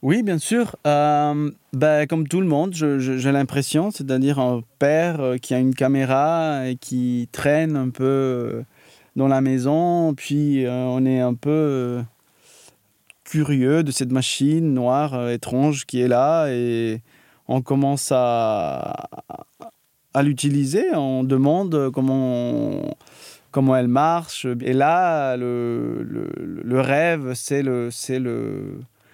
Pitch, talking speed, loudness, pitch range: 135 Hz, 135 wpm, -21 LUFS, 125-150 Hz